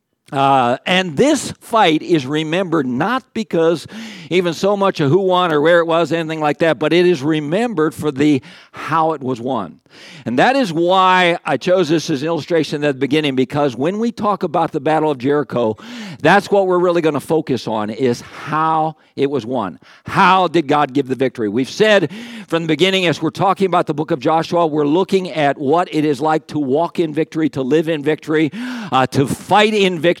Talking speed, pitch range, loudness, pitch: 210 wpm, 150-185 Hz, -16 LUFS, 160 Hz